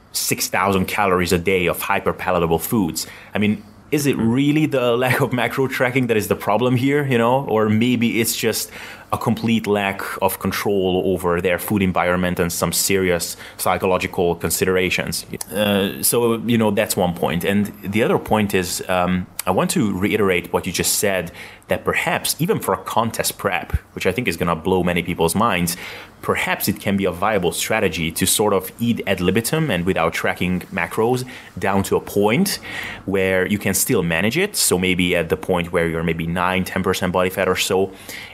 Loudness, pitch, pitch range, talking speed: -19 LUFS, 95 Hz, 90-115 Hz, 190 wpm